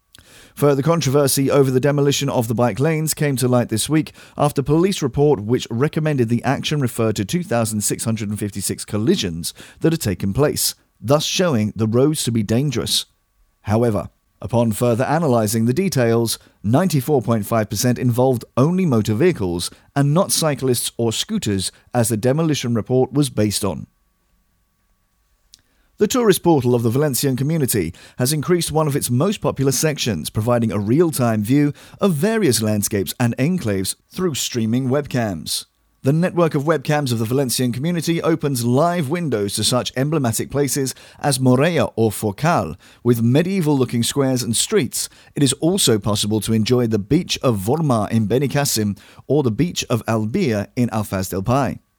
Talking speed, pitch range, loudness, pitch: 155 wpm, 110-145 Hz, -19 LUFS, 125 Hz